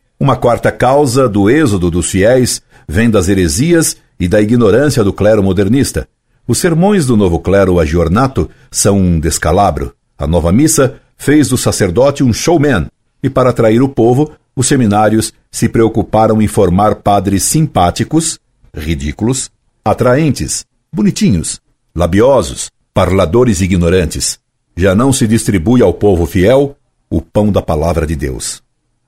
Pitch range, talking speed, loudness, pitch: 95-130 Hz, 135 wpm, -11 LUFS, 110 Hz